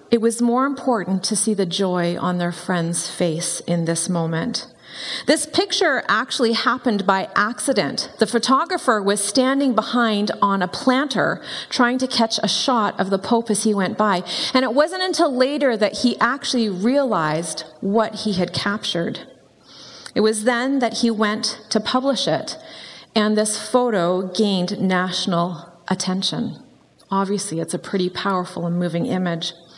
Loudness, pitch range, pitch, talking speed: -20 LUFS, 180-245 Hz, 215 Hz, 155 wpm